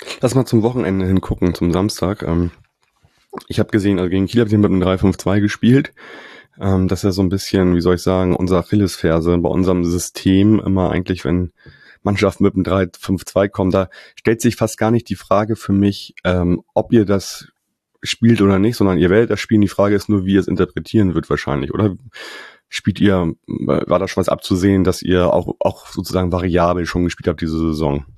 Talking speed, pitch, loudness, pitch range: 195 wpm, 95 Hz, -17 LUFS, 90-100 Hz